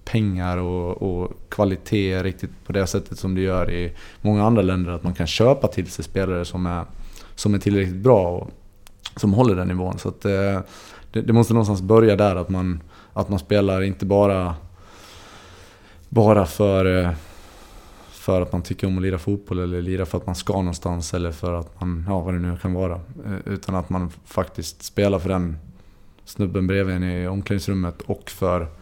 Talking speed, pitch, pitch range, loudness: 185 wpm, 95 Hz, 90-100 Hz, -22 LUFS